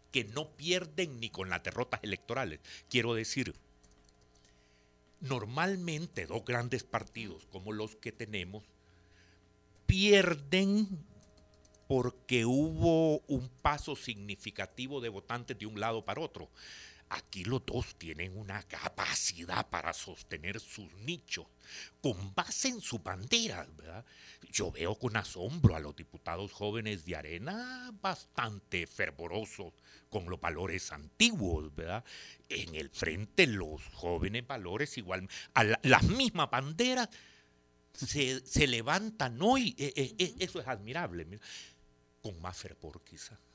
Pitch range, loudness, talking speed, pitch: 90-140 Hz, -34 LUFS, 120 wpm, 110 Hz